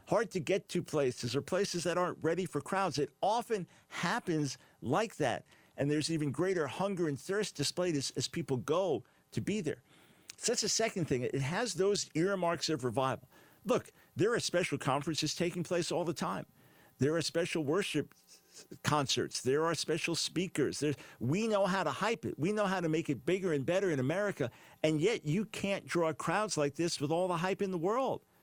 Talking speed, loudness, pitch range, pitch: 200 wpm, -34 LUFS, 145-190 Hz, 170 Hz